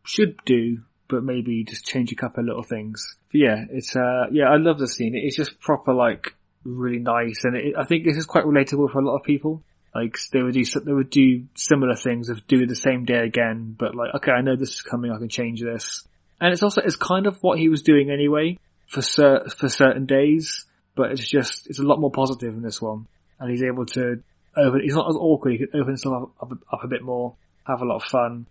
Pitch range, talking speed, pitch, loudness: 120-145 Hz, 245 wpm, 130 Hz, -22 LUFS